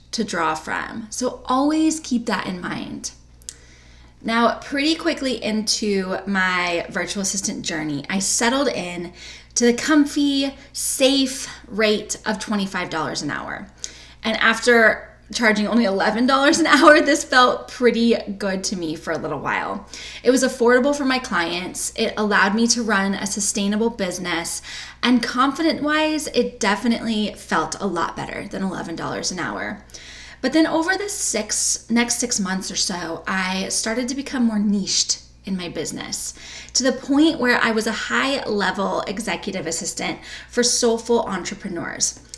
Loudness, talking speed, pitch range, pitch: -20 LUFS, 145 wpm, 185-250 Hz, 220 Hz